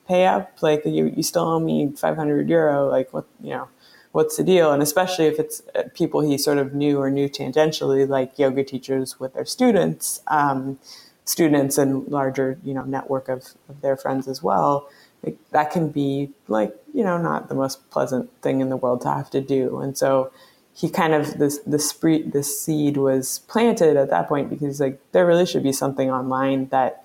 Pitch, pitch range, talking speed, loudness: 140 Hz, 135-155 Hz, 205 wpm, -21 LUFS